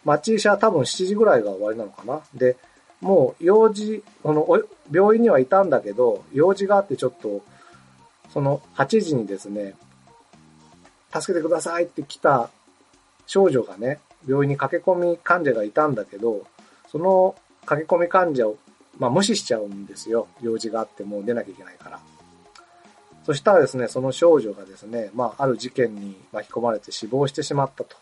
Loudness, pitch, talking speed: -21 LUFS, 135 Hz, 340 characters per minute